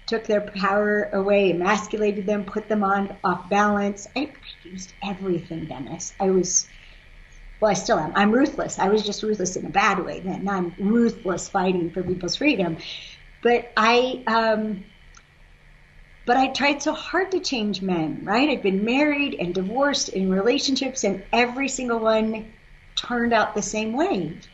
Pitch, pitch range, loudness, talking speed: 210 Hz, 190-235 Hz, -23 LUFS, 160 wpm